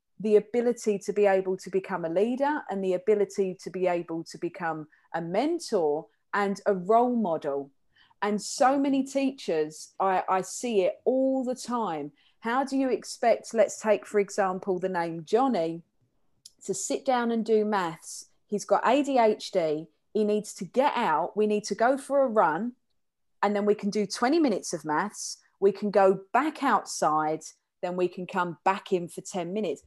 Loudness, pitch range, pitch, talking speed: -27 LUFS, 180-230 Hz, 200 Hz, 180 wpm